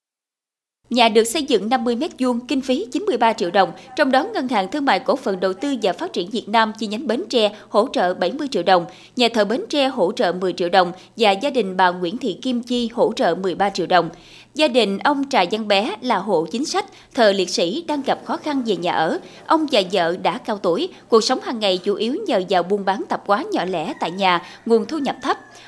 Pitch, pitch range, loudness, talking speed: 225 Hz, 190-270 Hz, -20 LUFS, 240 wpm